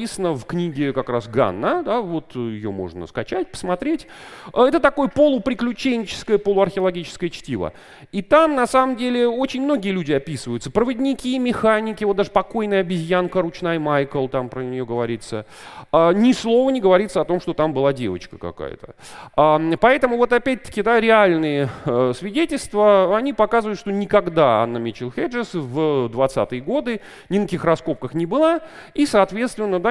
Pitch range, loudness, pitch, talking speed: 145-240 Hz, -20 LUFS, 195 Hz, 145 wpm